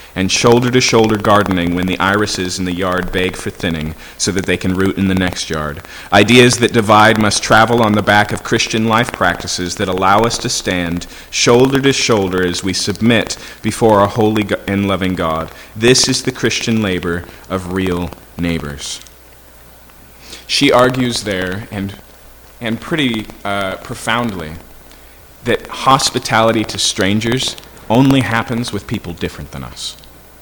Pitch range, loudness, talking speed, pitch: 90-115 Hz, -14 LUFS, 150 wpm, 100 Hz